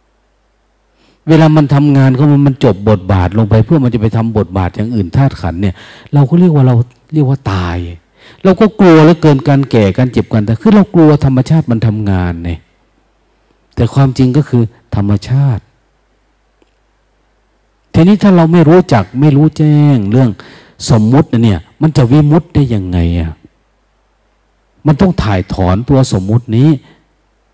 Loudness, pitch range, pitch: -10 LUFS, 105-150 Hz, 125 Hz